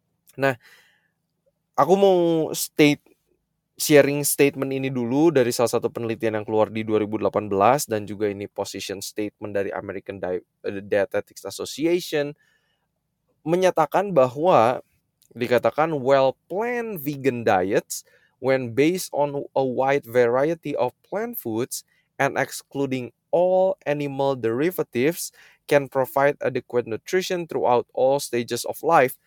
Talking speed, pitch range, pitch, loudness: 115 wpm, 120-160 Hz, 140 Hz, -23 LUFS